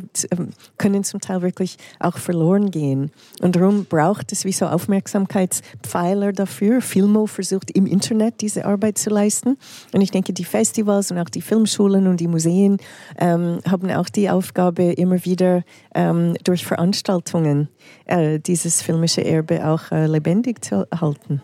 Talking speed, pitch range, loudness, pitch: 150 wpm, 170-200 Hz, -19 LUFS, 185 Hz